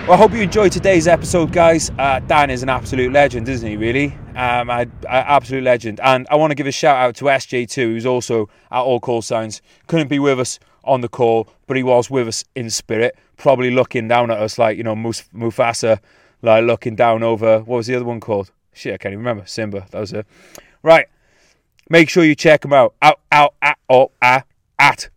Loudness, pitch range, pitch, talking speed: -16 LUFS, 115-145 Hz, 125 Hz, 230 wpm